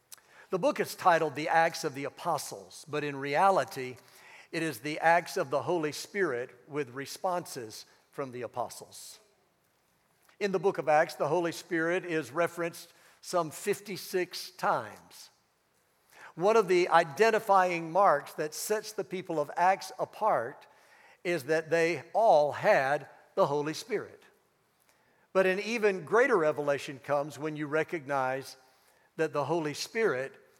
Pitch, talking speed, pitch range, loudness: 165 Hz, 140 wpm, 150-185 Hz, -30 LUFS